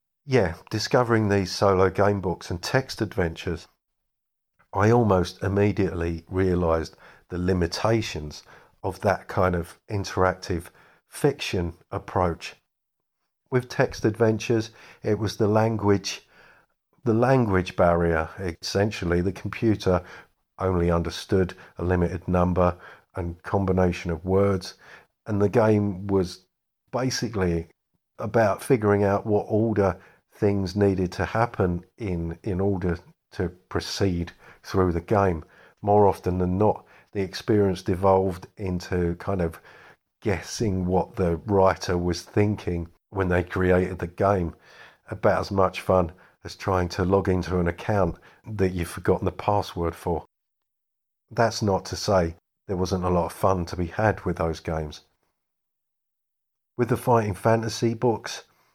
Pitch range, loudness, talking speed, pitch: 90-105 Hz, -25 LUFS, 130 wpm, 95 Hz